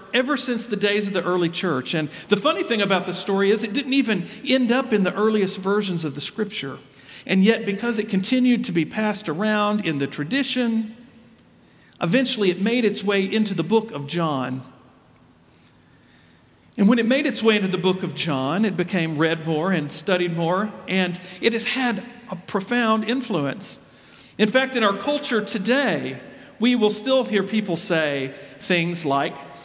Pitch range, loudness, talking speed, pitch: 175-230 Hz, -22 LUFS, 180 wpm, 205 Hz